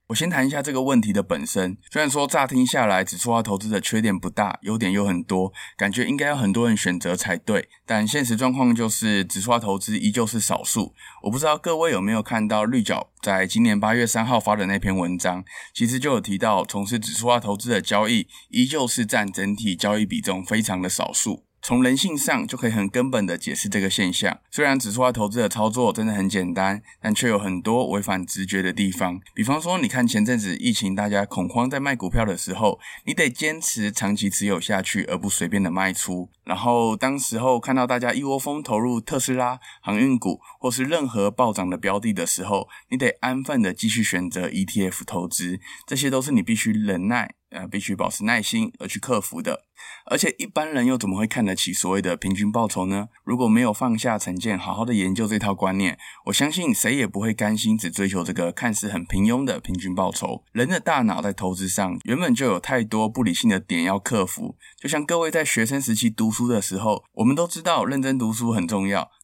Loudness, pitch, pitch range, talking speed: -23 LUFS, 110 Hz, 100-135 Hz, 330 characters per minute